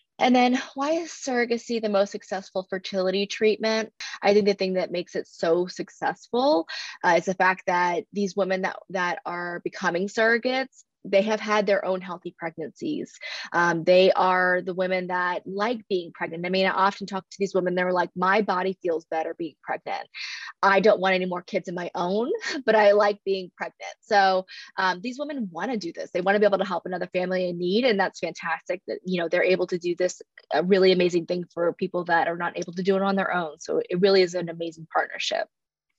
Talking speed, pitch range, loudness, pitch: 215 wpm, 180-210 Hz, -25 LUFS, 190 Hz